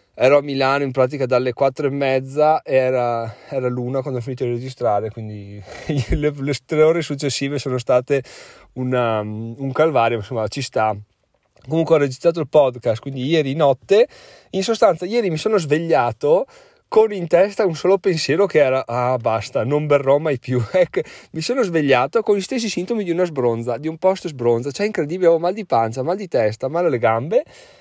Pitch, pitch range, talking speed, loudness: 140 Hz, 125-175 Hz, 185 wpm, -19 LUFS